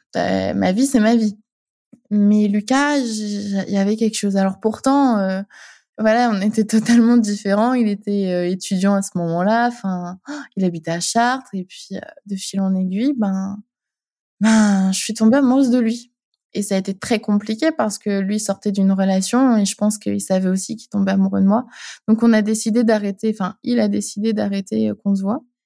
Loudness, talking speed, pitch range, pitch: -18 LUFS, 190 wpm, 195-235 Hz, 210 Hz